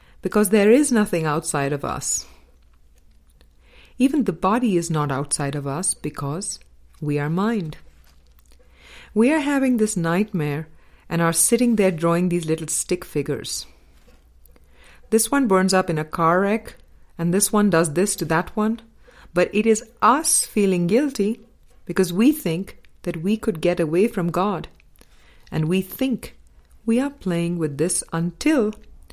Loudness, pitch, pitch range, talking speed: -21 LUFS, 175 Hz, 150-215 Hz, 150 wpm